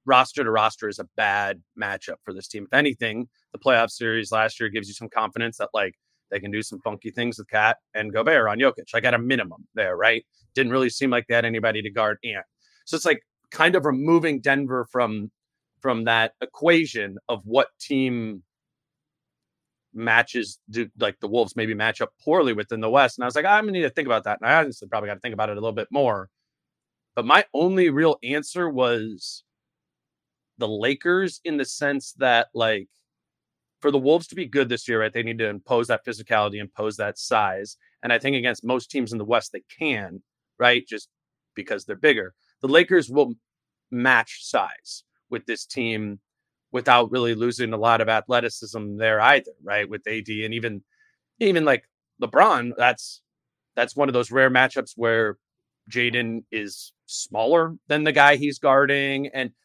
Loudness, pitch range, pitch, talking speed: -22 LUFS, 110-140 Hz, 120 Hz, 195 wpm